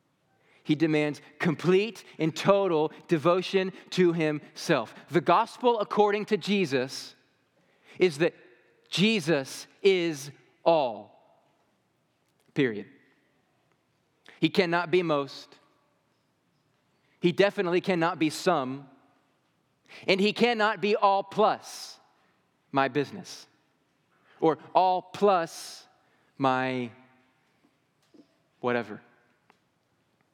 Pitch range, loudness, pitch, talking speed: 140-195 Hz, -27 LUFS, 165 Hz, 80 wpm